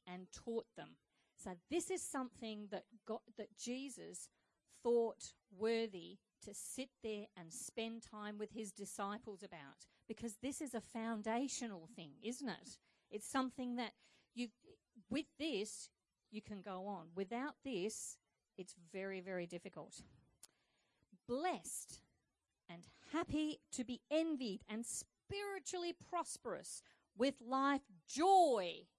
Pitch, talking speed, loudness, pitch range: 225 Hz, 120 wpm, -44 LUFS, 200-265 Hz